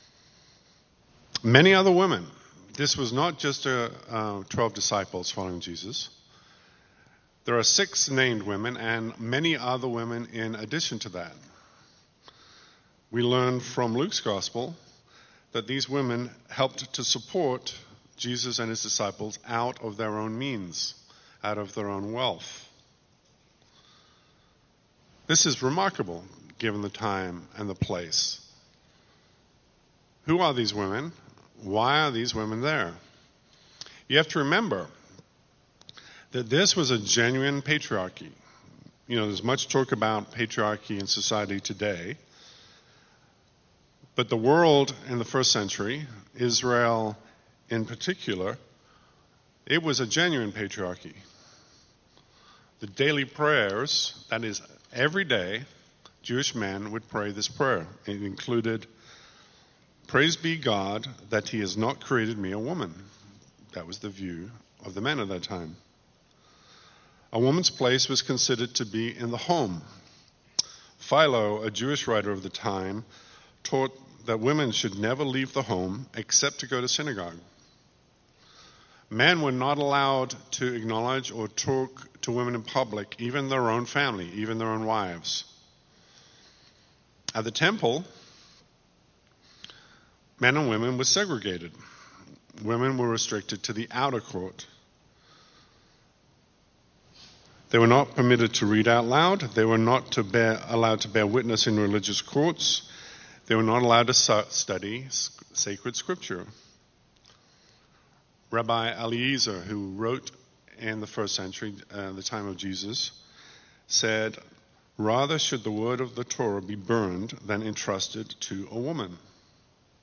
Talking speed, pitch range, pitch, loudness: 130 wpm, 105-130 Hz, 115 Hz, -27 LUFS